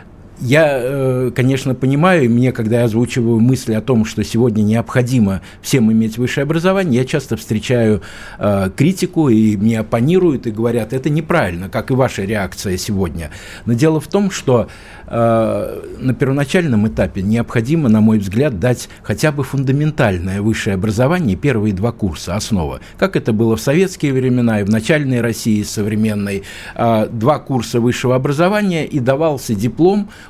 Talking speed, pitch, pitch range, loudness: 150 wpm, 120 Hz, 110-135 Hz, -16 LUFS